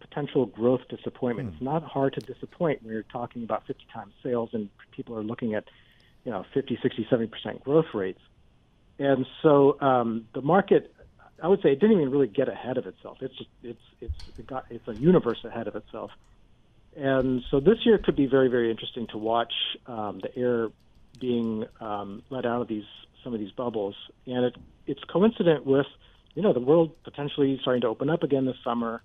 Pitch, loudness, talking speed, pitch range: 125 Hz, -26 LUFS, 200 wpm, 115-140 Hz